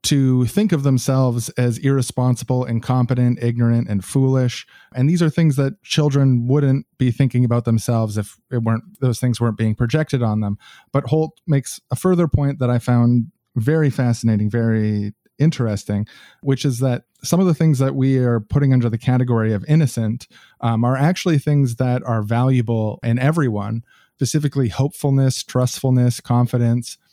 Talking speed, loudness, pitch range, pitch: 160 wpm, -19 LUFS, 115-140 Hz, 125 Hz